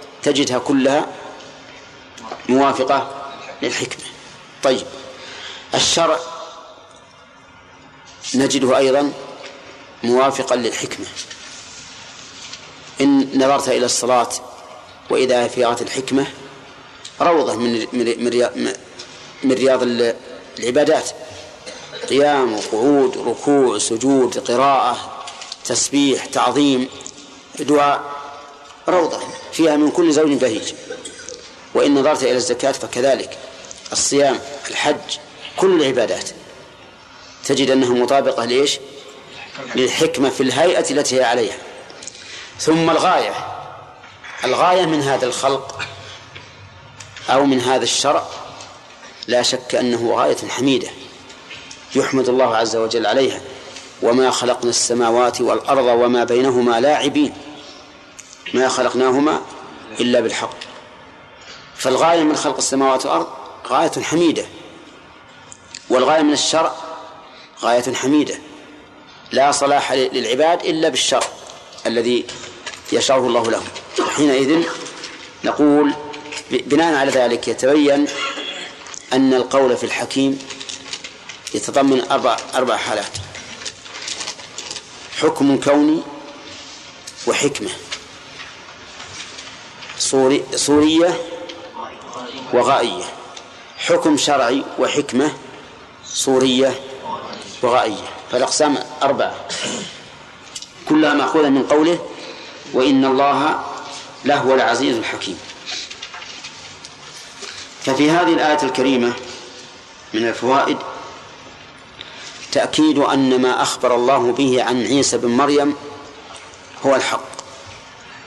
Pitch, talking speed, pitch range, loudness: 135 Hz, 80 wpm, 125-145 Hz, -17 LUFS